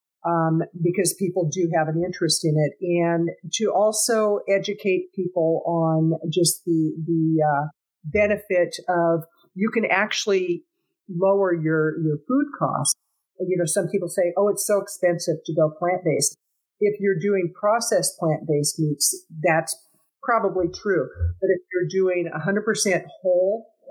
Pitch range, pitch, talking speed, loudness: 165-195 Hz, 180 Hz, 150 wpm, -22 LUFS